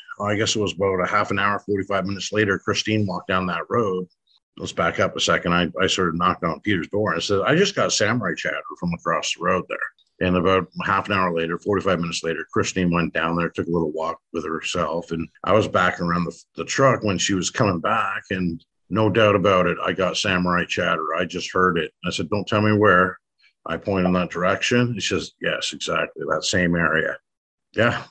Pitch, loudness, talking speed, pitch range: 95 Hz, -22 LUFS, 230 wpm, 85-105 Hz